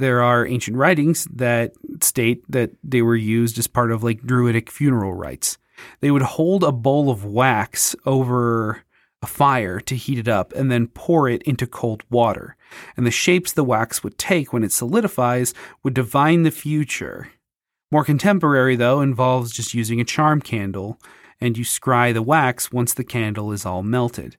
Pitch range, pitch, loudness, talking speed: 115-140 Hz, 125 Hz, -19 LUFS, 175 wpm